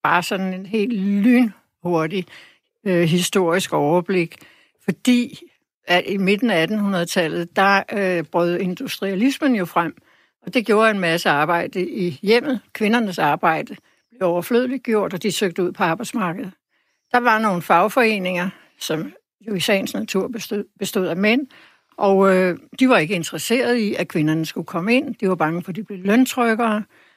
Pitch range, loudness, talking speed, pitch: 180-230 Hz, -20 LUFS, 160 wpm, 195 Hz